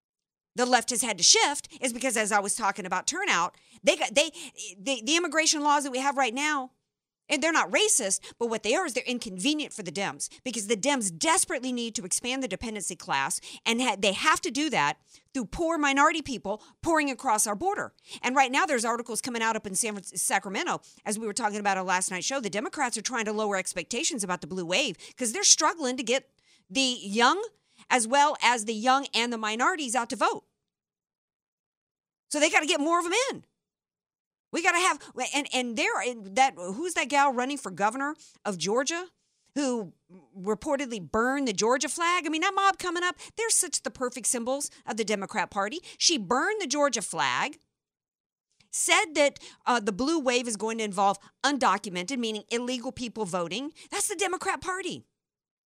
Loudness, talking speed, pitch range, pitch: -27 LUFS, 200 wpm, 215-300 Hz, 255 Hz